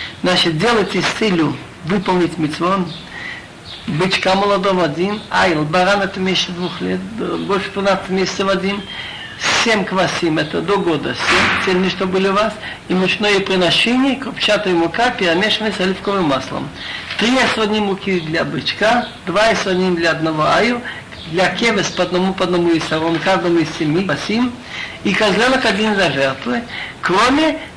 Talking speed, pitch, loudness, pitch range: 150 wpm, 190 Hz, -16 LUFS, 170-210 Hz